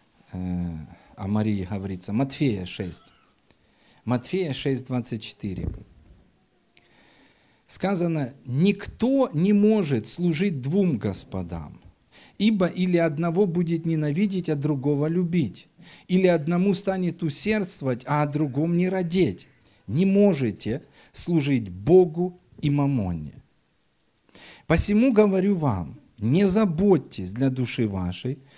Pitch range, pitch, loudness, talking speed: 110-185 Hz, 150 Hz, -24 LUFS, 95 wpm